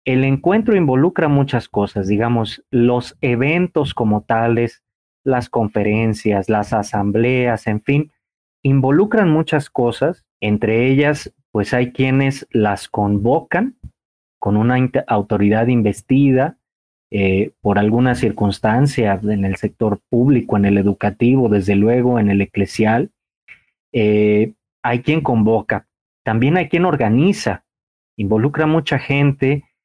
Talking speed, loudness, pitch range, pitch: 115 wpm, -17 LUFS, 105-135 Hz, 115 Hz